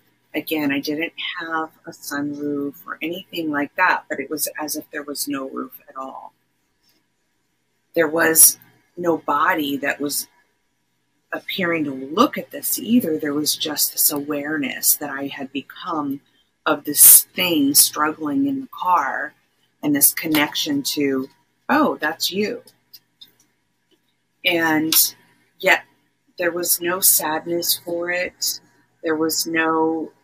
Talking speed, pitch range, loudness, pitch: 135 wpm, 140-165 Hz, -18 LUFS, 150 Hz